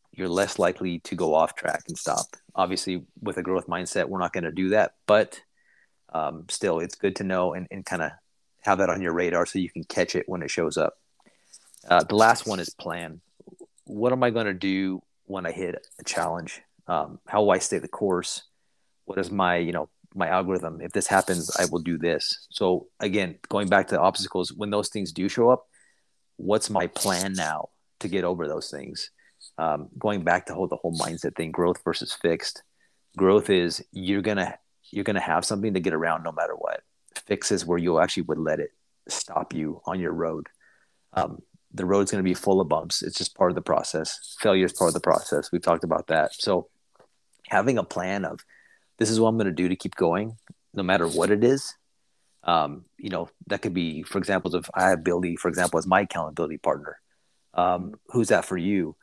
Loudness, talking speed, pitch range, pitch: -26 LUFS, 215 wpm, 85-100 Hz, 95 Hz